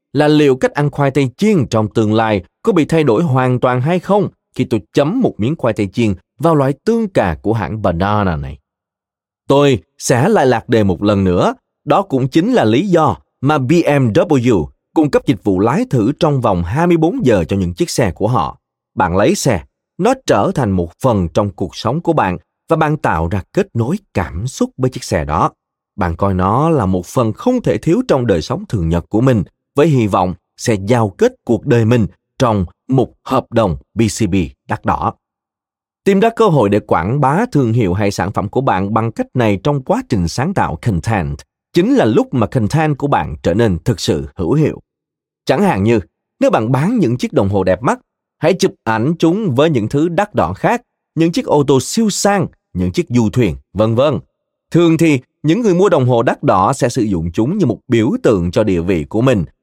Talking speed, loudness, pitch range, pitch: 215 wpm, -15 LUFS, 100-155 Hz, 120 Hz